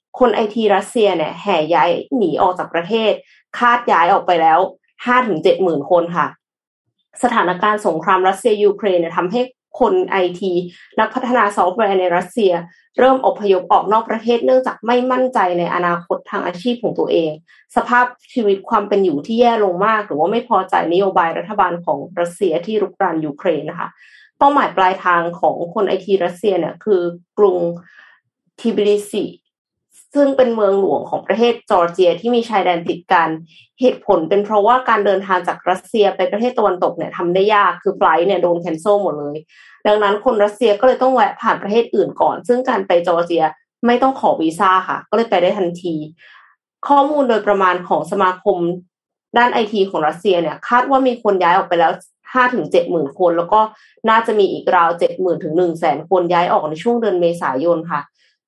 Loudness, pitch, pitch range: -16 LUFS, 195 Hz, 175-230 Hz